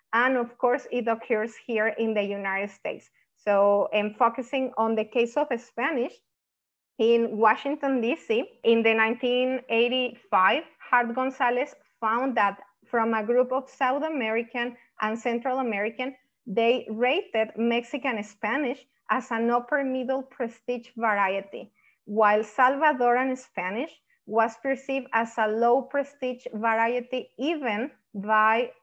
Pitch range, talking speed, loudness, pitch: 220-260 Hz, 125 wpm, -26 LUFS, 240 Hz